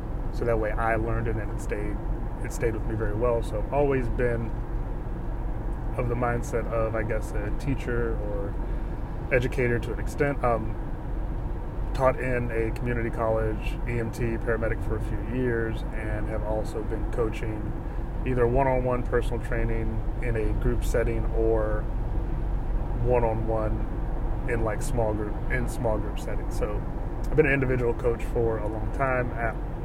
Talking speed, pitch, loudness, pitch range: 165 wpm, 115 Hz, -28 LUFS, 110-120 Hz